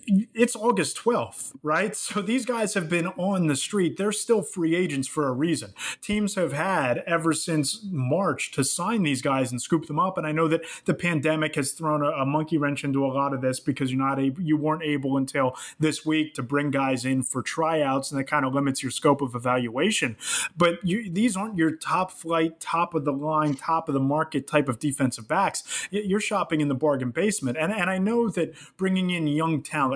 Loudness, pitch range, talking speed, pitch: -25 LUFS, 140-185 Hz, 215 wpm, 155 Hz